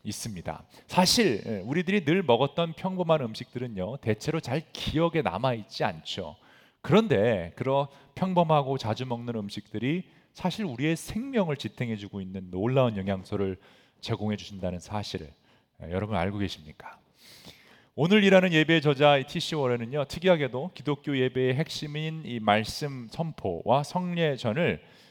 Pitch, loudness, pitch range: 135 Hz, -27 LUFS, 105-160 Hz